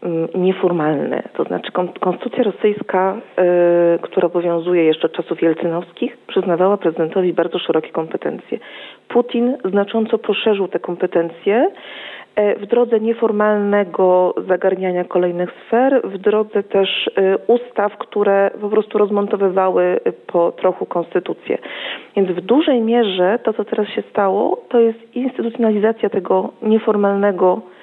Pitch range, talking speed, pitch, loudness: 180-220 Hz, 110 wpm, 195 Hz, -17 LUFS